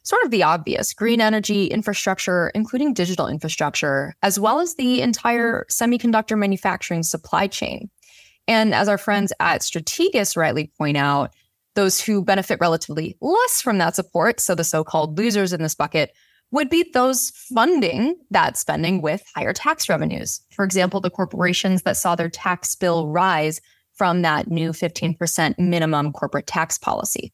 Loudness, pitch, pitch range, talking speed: -20 LUFS, 190 Hz, 170-225 Hz, 155 wpm